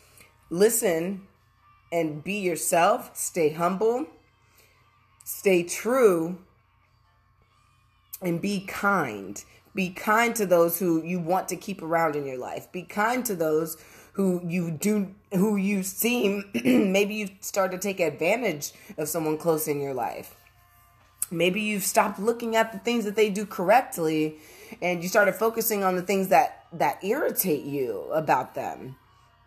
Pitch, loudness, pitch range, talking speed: 180 Hz, -25 LUFS, 140-210 Hz, 145 wpm